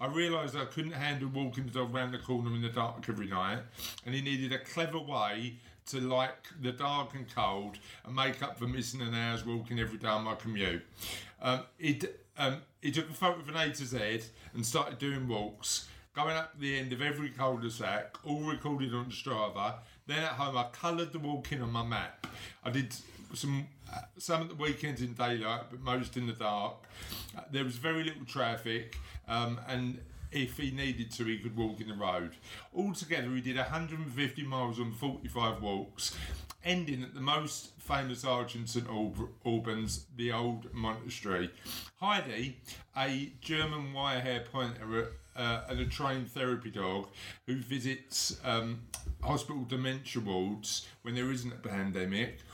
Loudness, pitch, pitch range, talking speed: -36 LUFS, 125 Hz, 115-140 Hz, 175 wpm